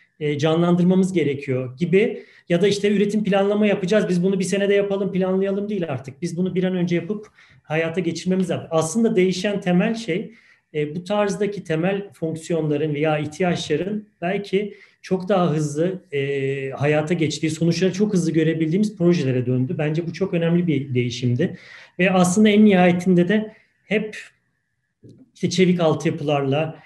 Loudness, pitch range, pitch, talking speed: -21 LUFS, 160-200 Hz, 175 Hz, 140 wpm